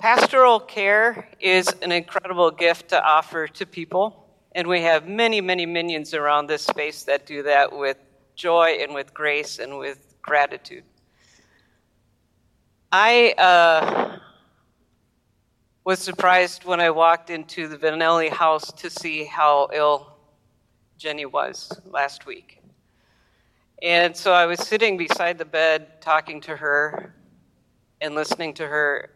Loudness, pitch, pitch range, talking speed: -20 LUFS, 160 Hz, 150-180 Hz, 130 wpm